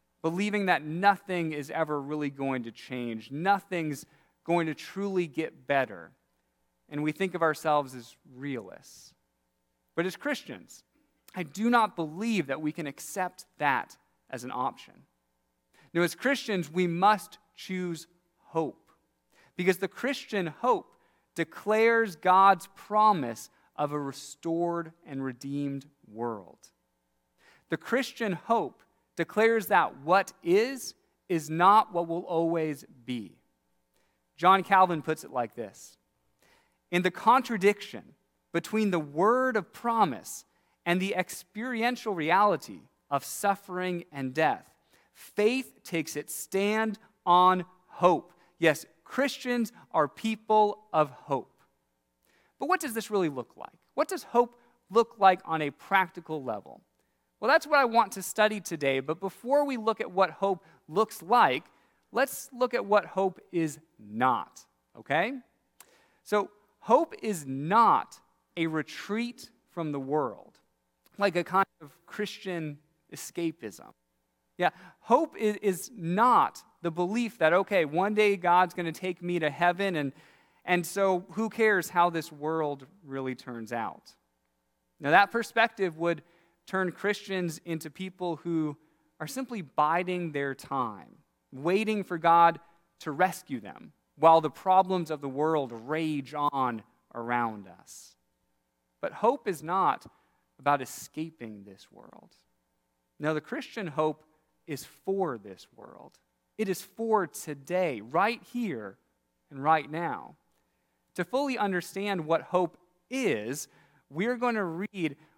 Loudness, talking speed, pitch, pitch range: -29 LUFS, 130 wpm, 170 Hz, 145-200 Hz